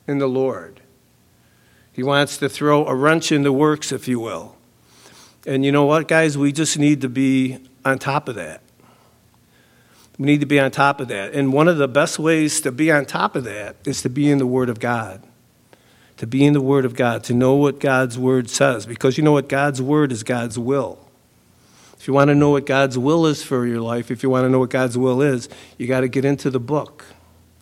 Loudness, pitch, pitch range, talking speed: -18 LUFS, 135 Hz, 130-145 Hz, 230 wpm